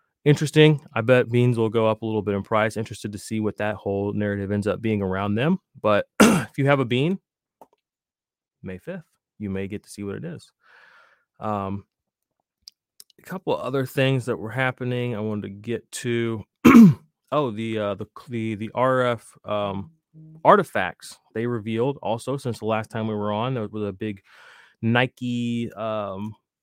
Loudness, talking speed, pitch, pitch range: -23 LUFS, 180 wpm, 115 Hz, 105-130 Hz